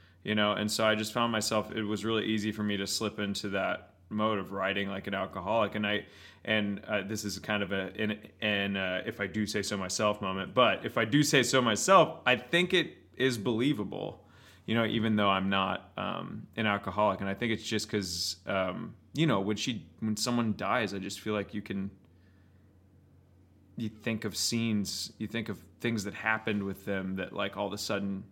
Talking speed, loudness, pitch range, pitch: 210 wpm, -31 LUFS, 95-110 Hz, 105 Hz